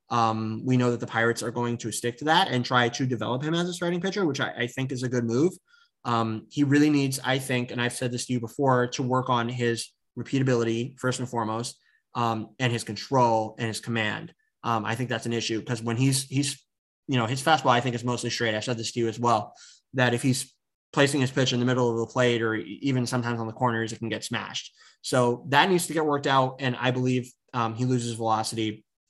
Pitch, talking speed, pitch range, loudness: 125 Hz, 245 wpm, 115-130 Hz, -26 LUFS